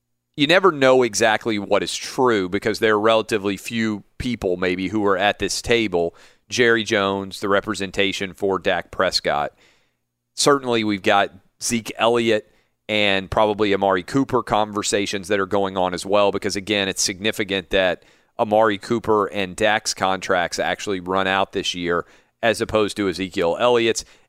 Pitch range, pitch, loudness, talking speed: 95-110 Hz, 105 Hz, -20 LUFS, 155 wpm